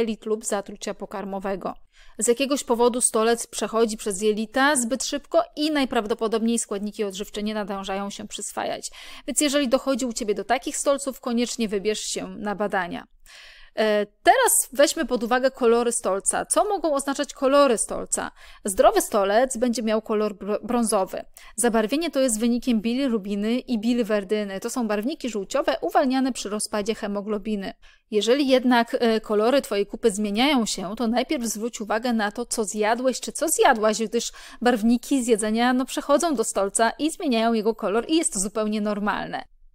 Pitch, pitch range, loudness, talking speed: 230 Hz, 215-265 Hz, -23 LUFS, 150 wpm